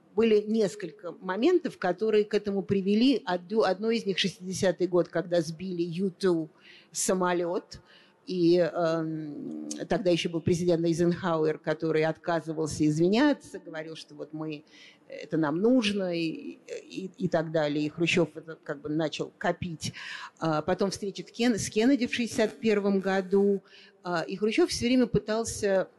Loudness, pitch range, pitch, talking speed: -28 LUFS, 165-205 Hz, 180 Hz, 135 wpm